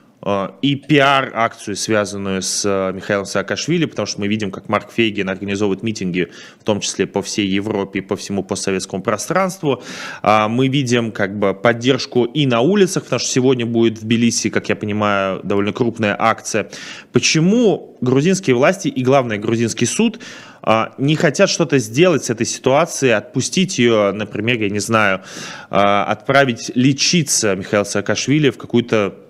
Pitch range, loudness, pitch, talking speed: 100-135 Hz, -17 LUFS, 115 Hz, 145 wpm